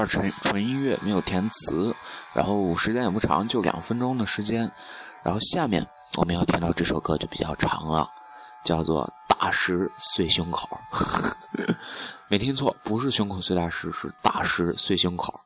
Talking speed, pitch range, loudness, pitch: 240 characters per minute, 85-125 Hz, -25 LUFS, 100 Hz